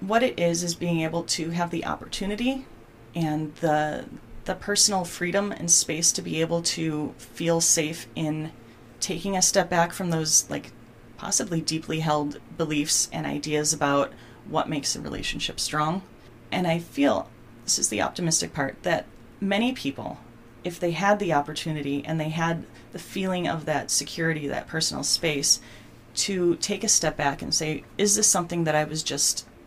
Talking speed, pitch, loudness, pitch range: 170 wpm, 160 Hz, -25 LUFS, 150-180 Hz